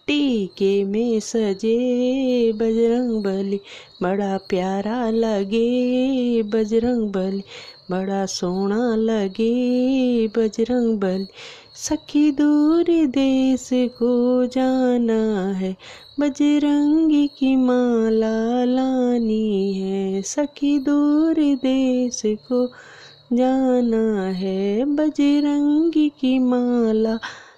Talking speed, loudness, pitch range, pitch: 75 wpm, -20 LUFS, 215-265 Hz, 240 Hz